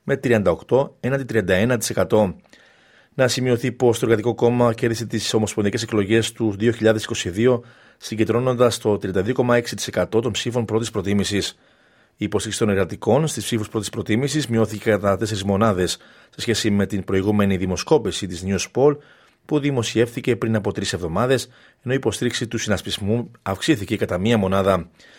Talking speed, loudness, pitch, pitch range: 140 wpm, -21 LUFS, 110 Hz, 100-120 Hz